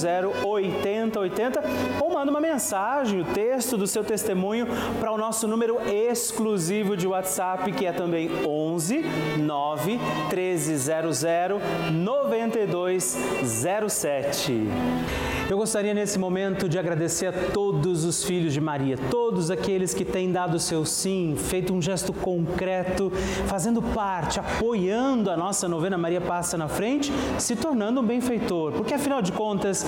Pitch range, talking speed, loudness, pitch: 170-220 Hz, 130 wpm, -25 LUFS, 190 Hz